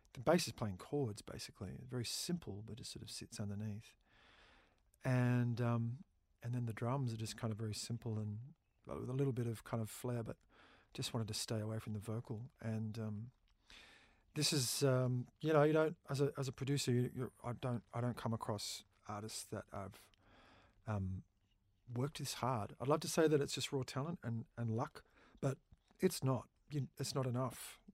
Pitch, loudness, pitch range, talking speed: 120 Hz, -41 LUFS, 110-135 Hz, 200 wpm